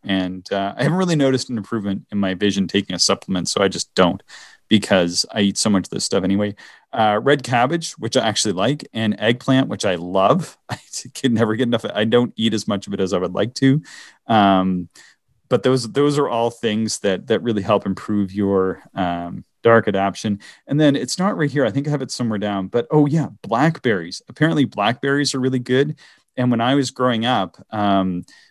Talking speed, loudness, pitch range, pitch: 215 wpm, -19 LUFS, 100-135 Hz, 115 Hz